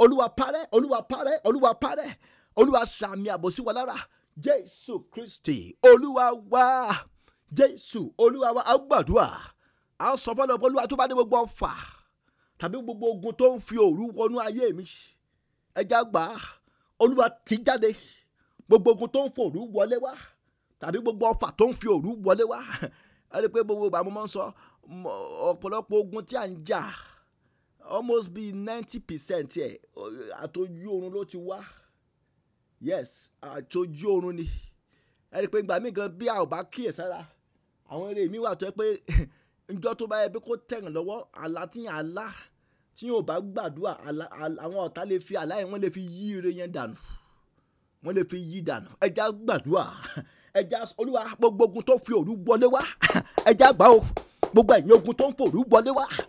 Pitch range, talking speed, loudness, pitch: 190-255 Hz, 160 wpm, -25 LUFS, 225 Hz